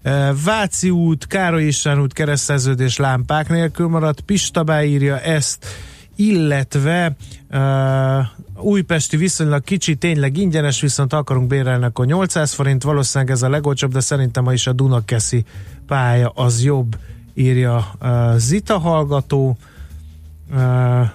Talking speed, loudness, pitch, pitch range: 115 wpm, -17 LUFS, 140 Hz, 125-155 Hz